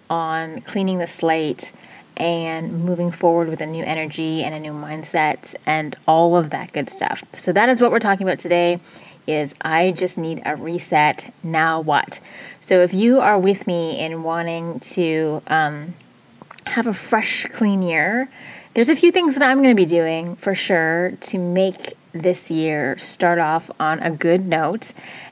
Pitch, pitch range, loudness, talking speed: 170 Hz, 160-190 Hz, -19 LUFS, 175 wpm